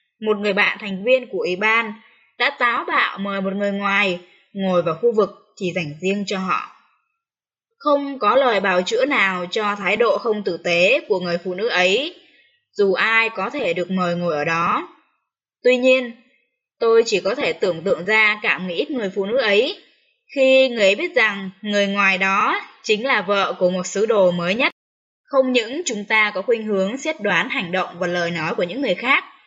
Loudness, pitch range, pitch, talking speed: -19 LUFS, 190-265 Hz, 210 Hz, 205 wpm